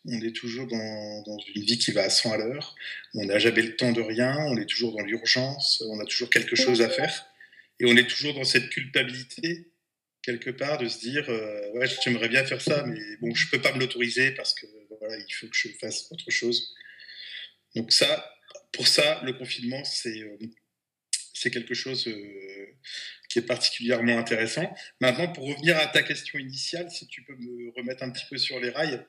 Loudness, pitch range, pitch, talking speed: -25 LUFS, 115-135 Hz, 125 Hz, 210 wpm